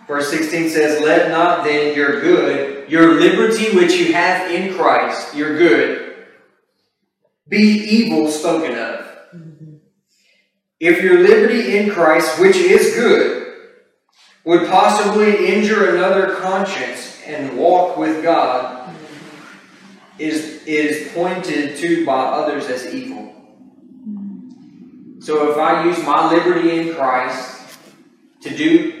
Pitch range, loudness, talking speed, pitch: 160-250 Hz, -15 LUFS, 115 wpm, 180 Hz